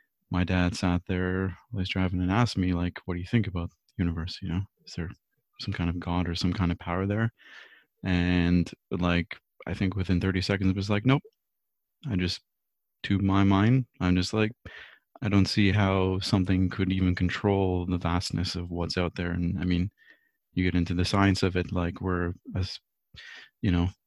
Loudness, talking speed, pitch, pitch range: -28 LUFS, 195 wpm, 90 Hz, 90-100 Hz